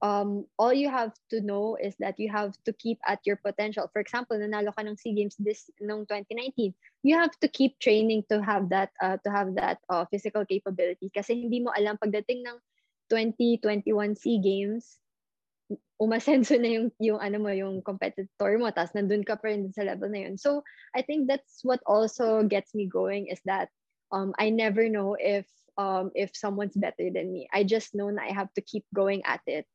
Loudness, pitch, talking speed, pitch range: -28 LUFS, 210 Hz, 200 wpm, 200-230 Hz